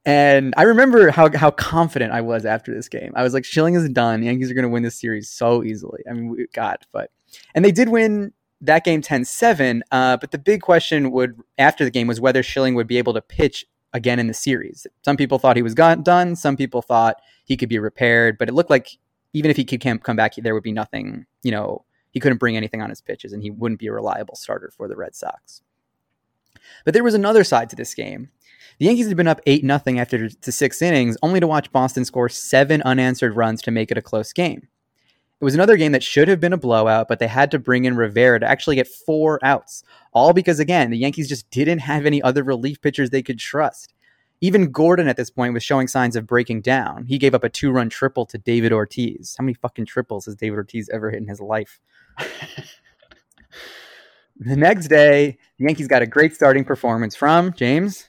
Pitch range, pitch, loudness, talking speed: 120-150 Hz, 130 Hz, -18 LUFS, 230 wpm